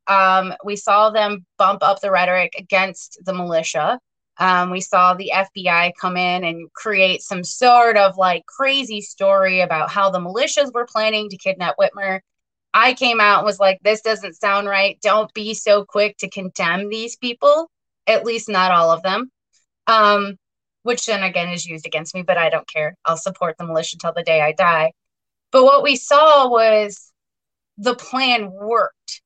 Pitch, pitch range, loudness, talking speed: 195 Hz, 180-220 Hz, -17 LUFS, 180 wpm